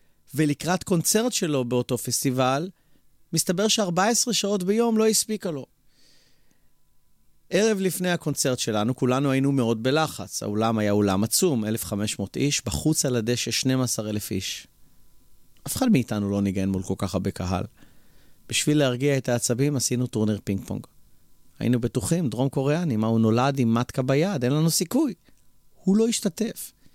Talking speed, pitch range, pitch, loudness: 145 wpm, 110-165 Hz, 130 Hz, -24 LUFS